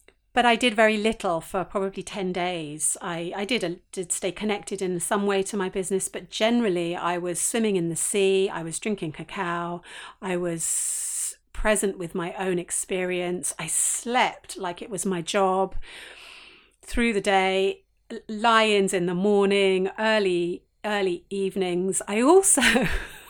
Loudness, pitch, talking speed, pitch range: -24 LUFS, 190 Hz, 155 wpm, 180-210 Hz